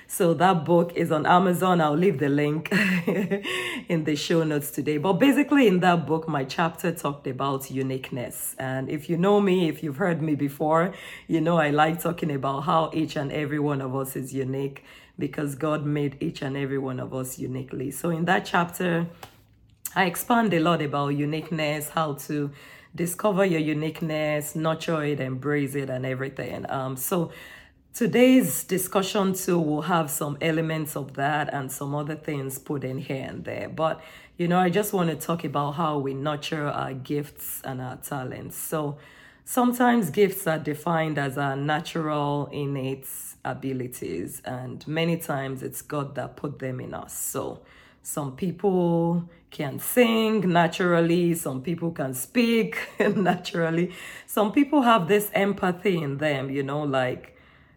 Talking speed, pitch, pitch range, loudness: 165 wpm, 155 Hz, 140-175 Hz, -25 LUFS